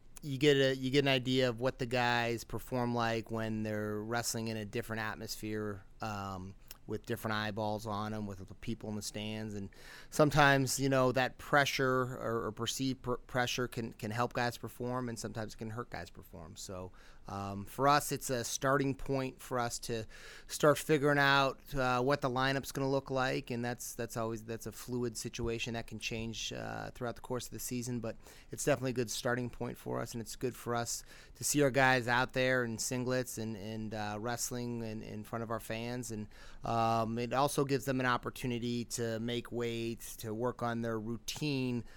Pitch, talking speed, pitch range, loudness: 120 Hz, 205 wpm, 110-130 Hz, -35 LUFS